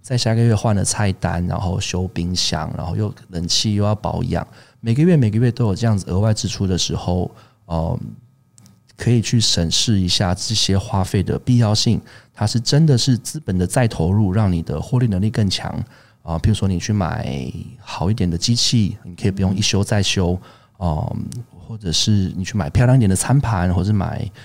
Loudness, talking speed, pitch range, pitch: -19 LUFS, 285 characters per minute, 95-115 Hz, 105 Hz